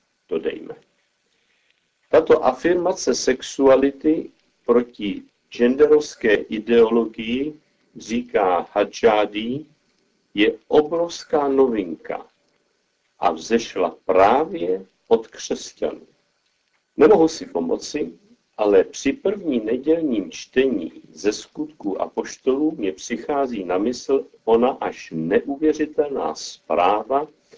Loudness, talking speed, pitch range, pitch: -21 LUFS, 85 wpm, 120-190 Hz, 150 Hz